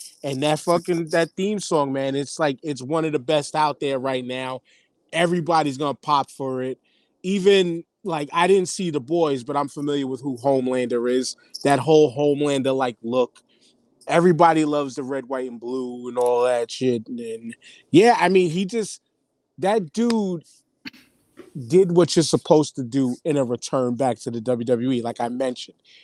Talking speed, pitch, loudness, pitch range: 180 wpm, 145 Hz, -22 LUFS, 130-170 Hz